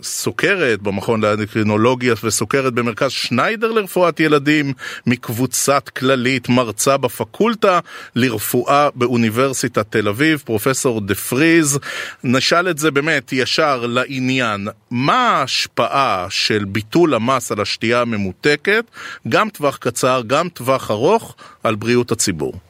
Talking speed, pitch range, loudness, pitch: 110 wpm, 115-140 Hz, -17 LUFS, 125 Hz